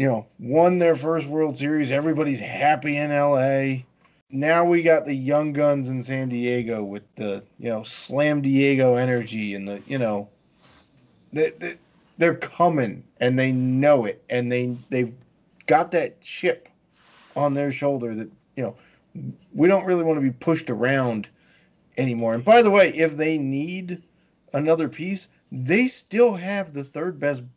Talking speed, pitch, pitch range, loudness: 165 wpm, 140 Hz, 125-160 Hz, -22 LUFS